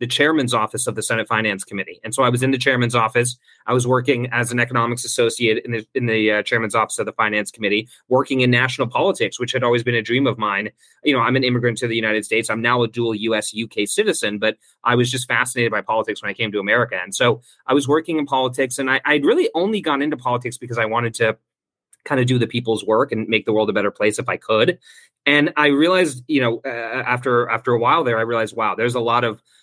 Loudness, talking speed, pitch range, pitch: -19 LUFS, 255 wpm, 110-130 Hz, 120 Hz